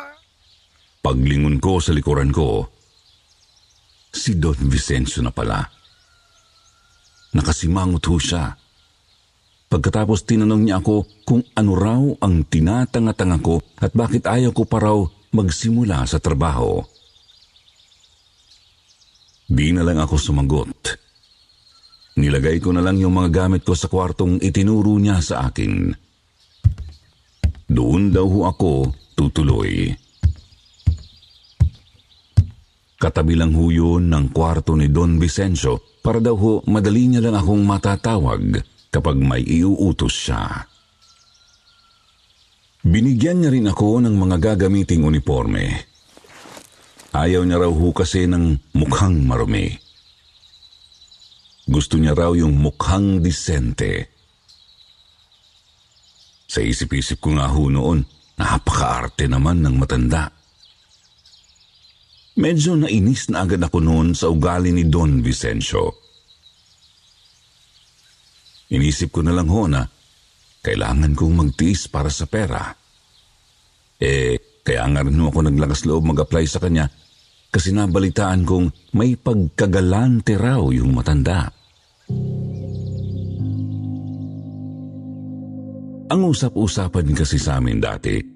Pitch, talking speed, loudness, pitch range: 90 Hz, 105 wpm, -18 LUFS, 80-105 Hz